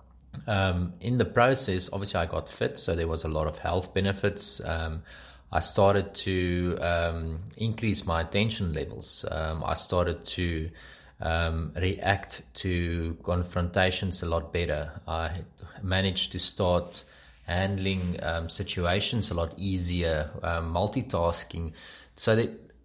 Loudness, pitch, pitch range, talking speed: -29 LUFS, 90 Hz, 80-95 Hz, 135 wpm